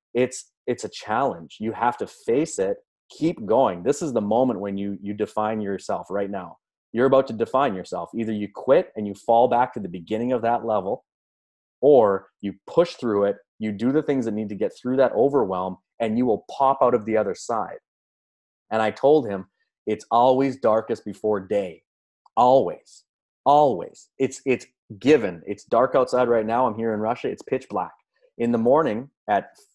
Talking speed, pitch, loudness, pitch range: 190 wpm, 110 Hz, -23 LUFS, 100-125 Hz